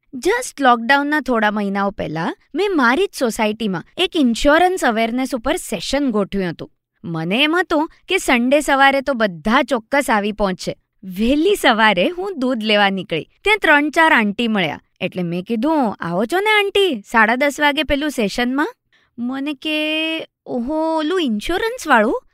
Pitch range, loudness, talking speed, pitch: 215-315 Hz, -17 LUFS, 145 wpm, 270 Hz